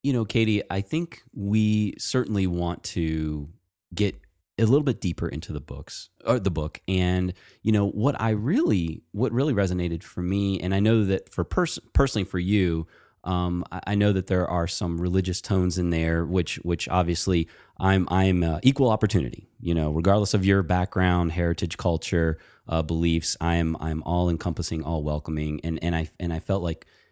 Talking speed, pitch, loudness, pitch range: 185 wpm, 90 Hz, -25 LUFS, 85-100 Hz